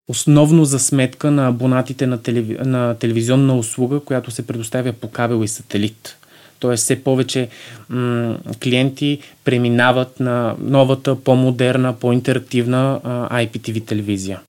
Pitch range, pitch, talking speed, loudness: 120-130 Hz, 125 Hz, 110 wpm, -17 LUFS